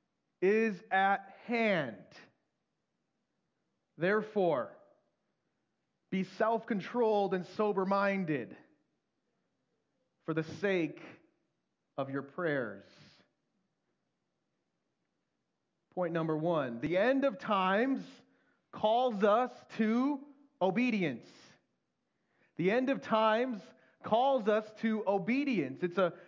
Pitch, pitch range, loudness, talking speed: 205 Hz, 180-235 Hz, -32 LUFS, 85 wpm